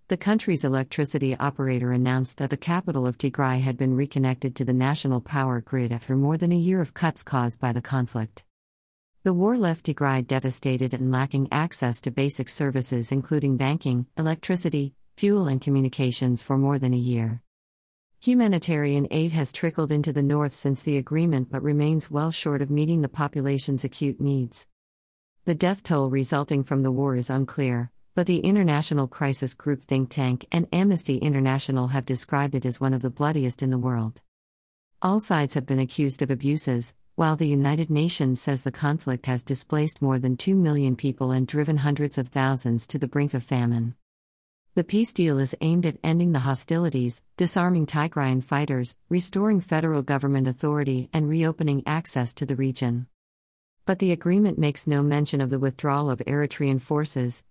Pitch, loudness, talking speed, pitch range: 140 Hz, -25 LUFS, 175 wpm, 130-150 Hz